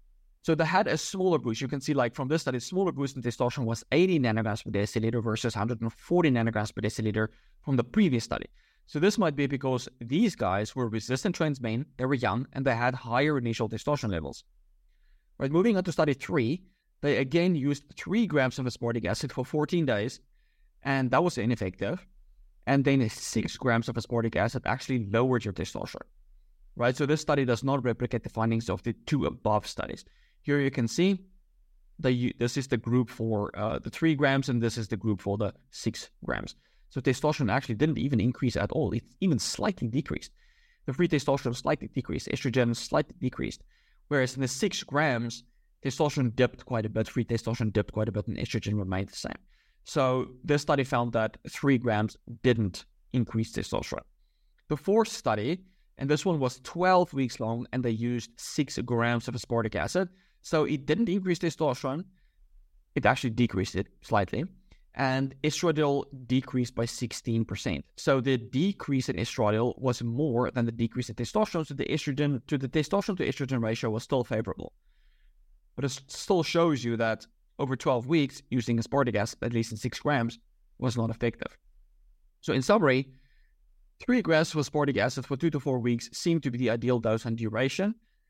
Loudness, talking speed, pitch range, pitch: -29 LUFS, 185 wpm, 115-145 Hz, 130 Hz